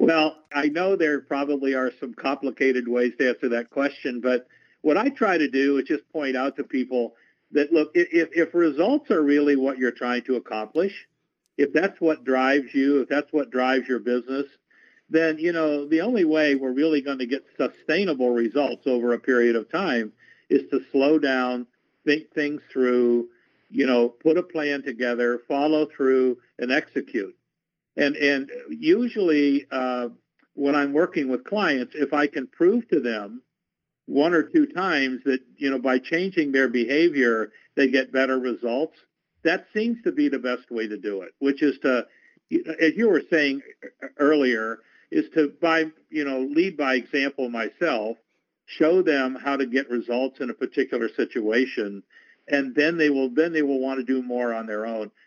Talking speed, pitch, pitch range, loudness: 180 wpm, 140 Hz, 125-155 Hz, -23 LUFS